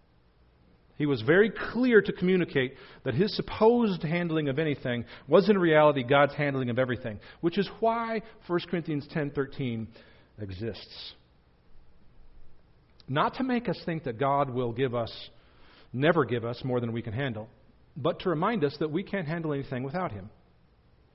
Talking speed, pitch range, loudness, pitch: 160 wpm, 115-175 Hz, -28 LUFS, 140 Hz